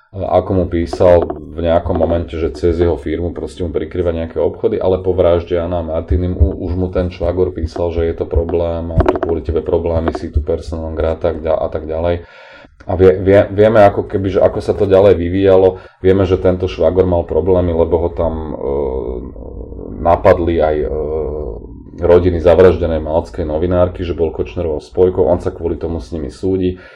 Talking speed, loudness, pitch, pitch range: 180 wpm, -15 LUFS, 85 Hz, 85-90 Hz